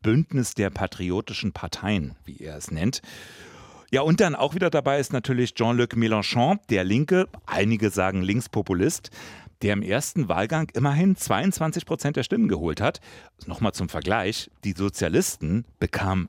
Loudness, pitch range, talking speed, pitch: -24 LUFS, 100-140 Hz, 145 wpm, 110 Hz